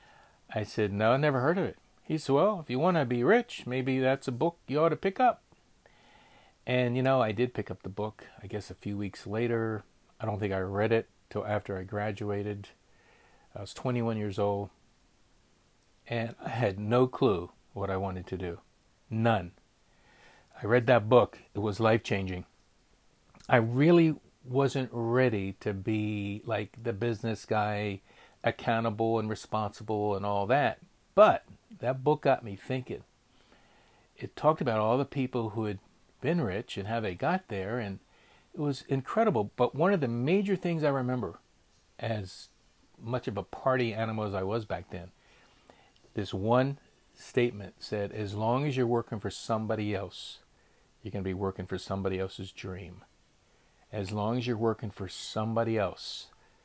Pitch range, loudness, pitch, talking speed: 100-130 Hz, -30 LUFS, 110 Hz, 175 wpm